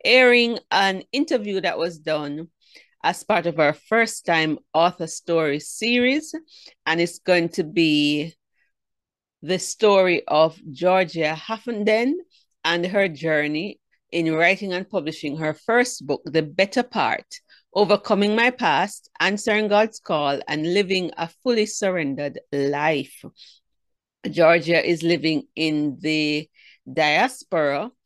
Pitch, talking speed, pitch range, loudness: 170 Hz, 120 wpm, 155-210 Hz, -21 LUFS